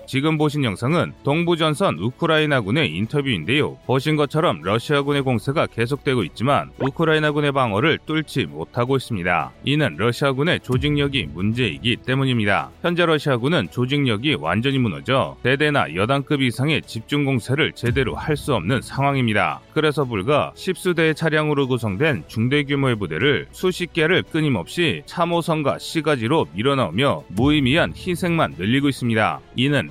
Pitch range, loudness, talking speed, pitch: 120-155 Hz, -20 LUFS, 375 characters per minute, 140 Hz